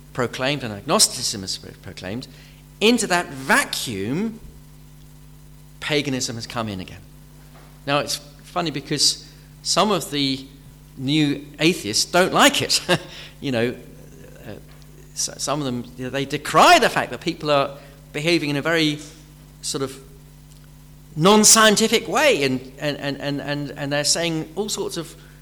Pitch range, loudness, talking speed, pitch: 140-155 Hz, -20 LUFS, 130 wpm, 145 Hz